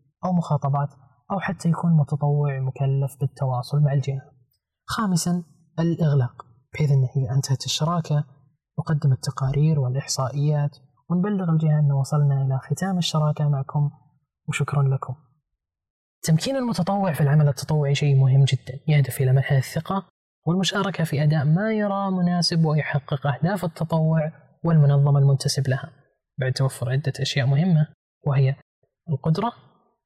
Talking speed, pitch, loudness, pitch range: 120 wpm, 145 Hz, -23 LUFS, 135-165 Hz